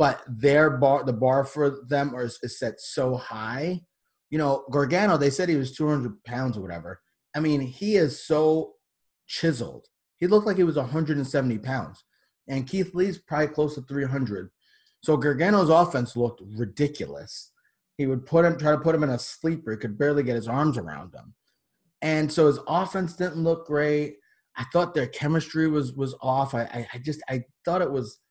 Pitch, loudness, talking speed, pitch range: 145 Hz, -25 LUFS, 190 wpm, 130-160 Hz